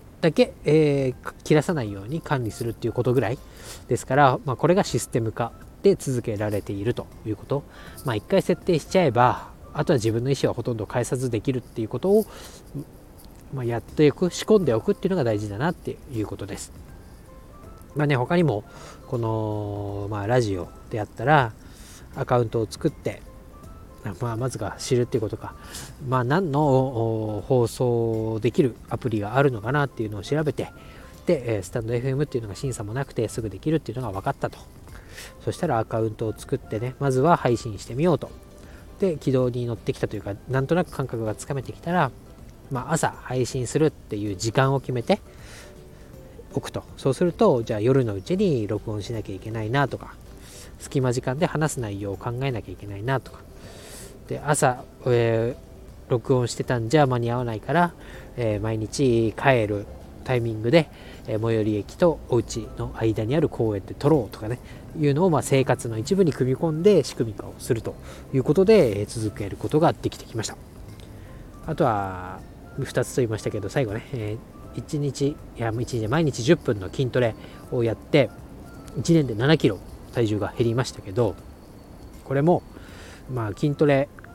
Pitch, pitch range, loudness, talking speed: 120 Hz, 110-140 Hz, -24 LUFS, 360 characters per minute